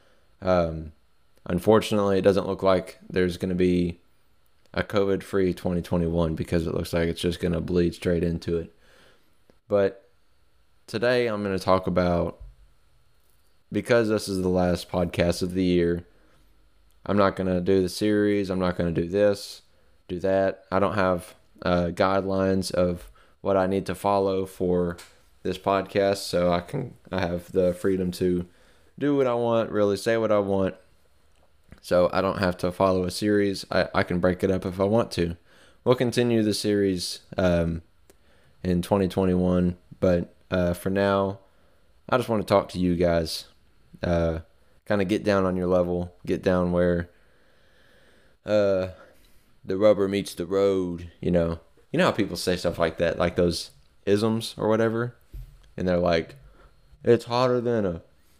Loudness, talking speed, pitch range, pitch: -25 LUFS, 170 wpm, 85-100 Hz, 90 Hz